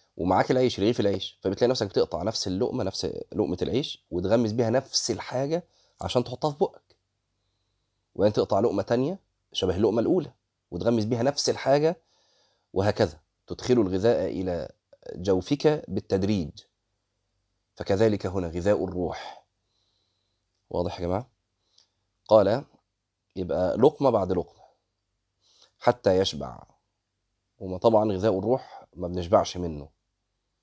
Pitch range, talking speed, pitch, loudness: 95-115 Hz, 115 wpm, 100 Hz, -26 LUFS